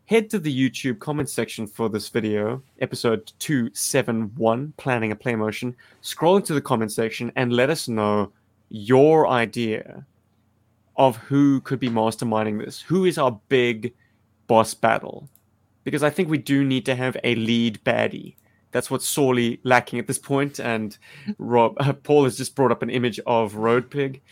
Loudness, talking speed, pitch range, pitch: -22 LUFS, 170 wpm, 110-135 Hz, 120 Hz